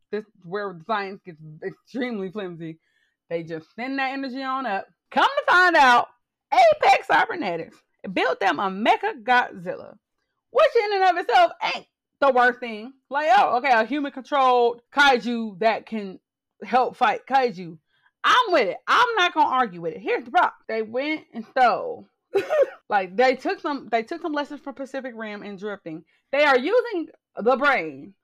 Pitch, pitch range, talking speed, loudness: 255 Hz, 210-310 Hz, 170 wpm, -22 LUFS